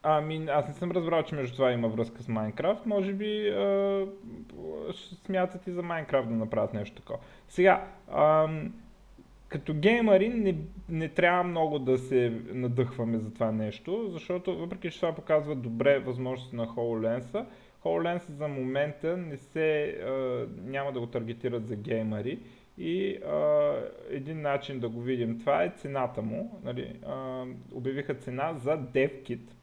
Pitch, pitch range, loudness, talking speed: 150 Hz, 125-180 Hz, -30 LUFS, 150 wpm